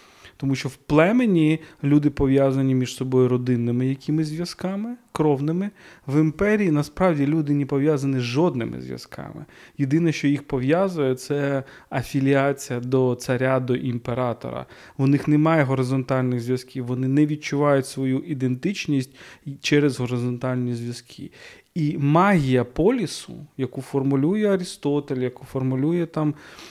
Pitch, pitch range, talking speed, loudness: 140 Hz, 130-155 Hz, 120 wpm, -22 LUFS